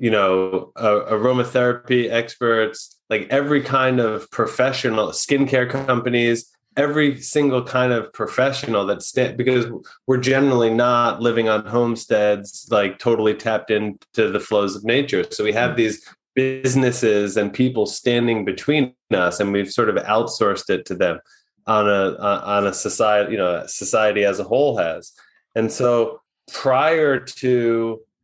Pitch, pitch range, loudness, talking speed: 120 Hz, 105-130 Hz, -19 LUFS, 145 wpm